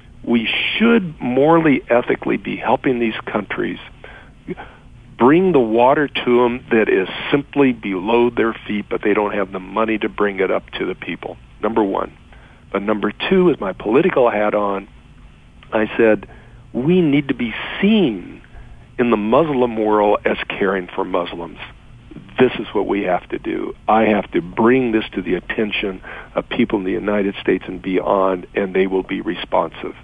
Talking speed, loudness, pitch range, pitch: 170 wpm, -18 LUFS, 105-130 Hz, 115 Hz